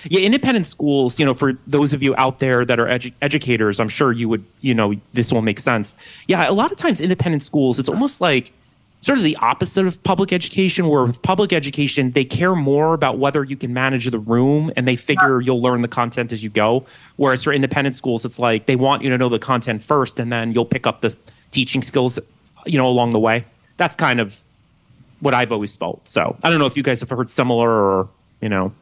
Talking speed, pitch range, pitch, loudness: 235 wpm, 120-150 Hz, 130 Hz, -18 LUFS